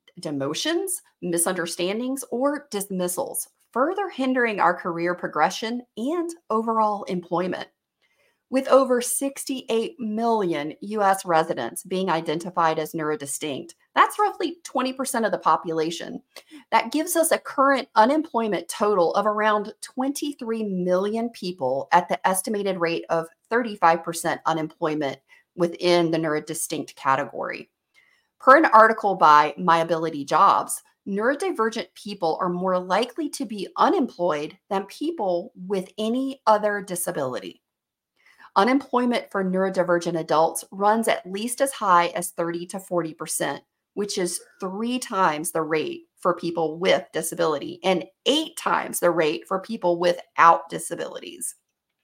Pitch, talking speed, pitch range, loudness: 195 Hz, 120 wpm, 170-245 Hz, -23 LUFS